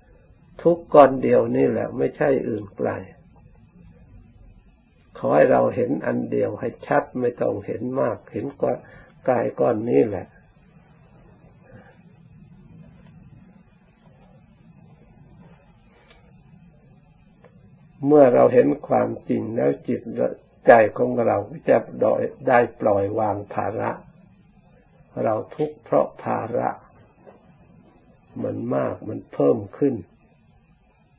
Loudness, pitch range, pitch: -21 LUFS, 120-165 Hz, 150 Hz